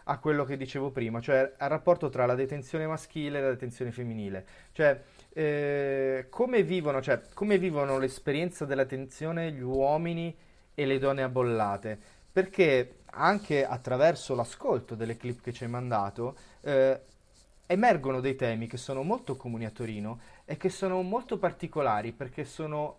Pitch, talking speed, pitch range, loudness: 135 Hz, 155 wpm, 125-155 Hz, -30 LUFS